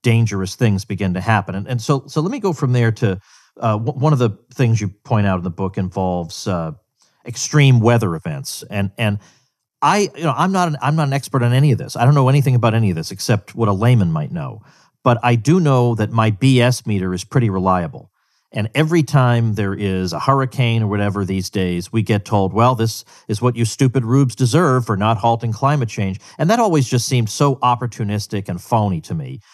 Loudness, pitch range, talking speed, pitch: -17 LUFS, 105-135 Hz, 225 wpm, 120 Hz